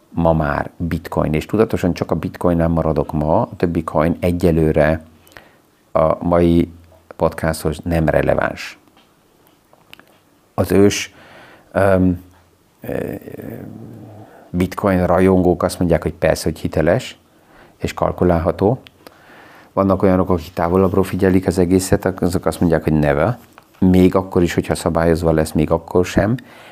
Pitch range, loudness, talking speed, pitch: 80-95 Hz, -17 LUFS, 120 wpm, 85 Hz